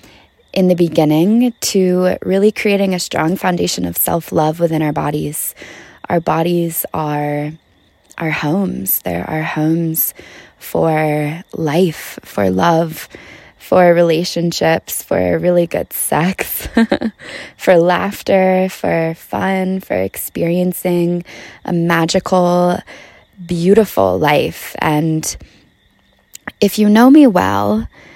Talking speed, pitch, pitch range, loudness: 105 wpm, 170 Hz, 155-185 Hz, -15 LUFS